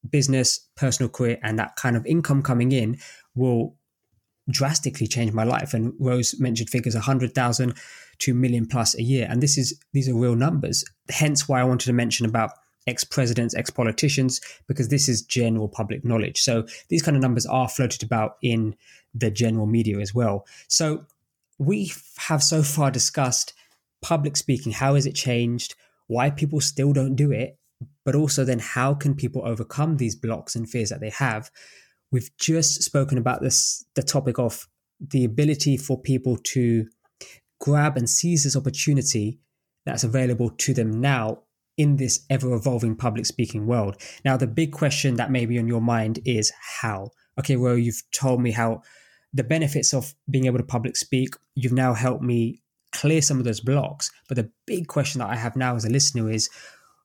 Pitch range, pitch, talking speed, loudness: 115-140 Hz, 125 Hz, 180 wpm, -23 LUFS